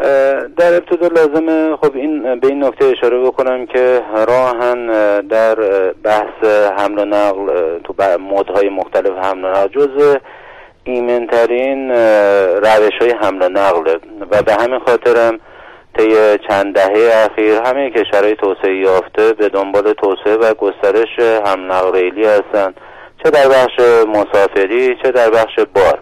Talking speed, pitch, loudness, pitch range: 140 wpm, 110 Hz, -12 LUFS, 100-135 Hz